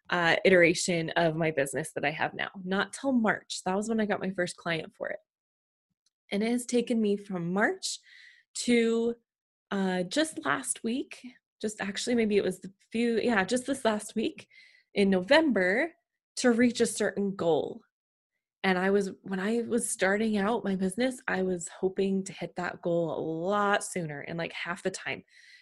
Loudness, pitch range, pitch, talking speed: -29 LUFS, 185-240 Hz, 205 Hz, 185 wpm